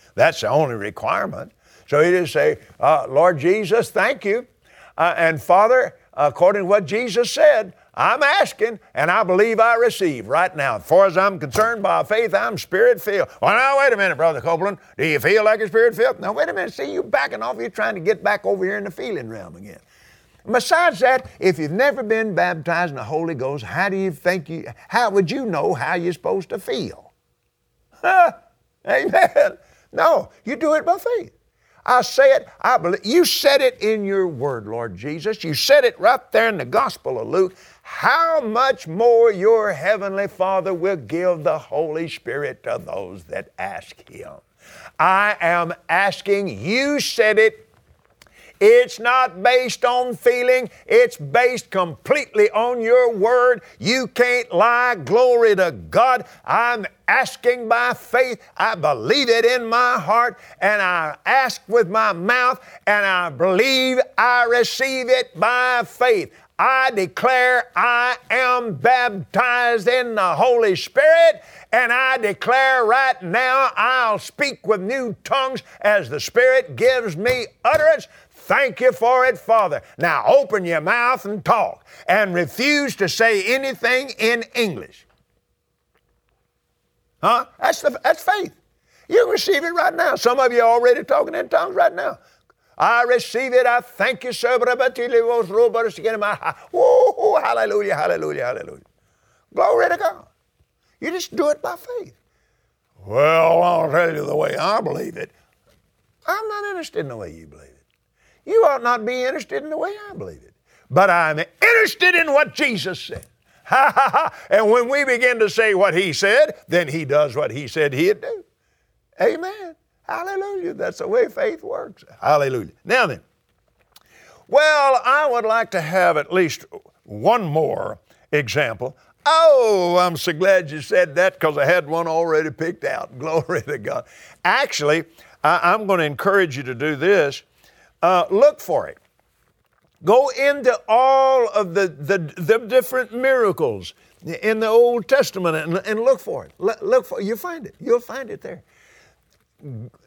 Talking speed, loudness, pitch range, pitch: 165 wpm, -18 LUFS, 190-285 Hz, 240 Hz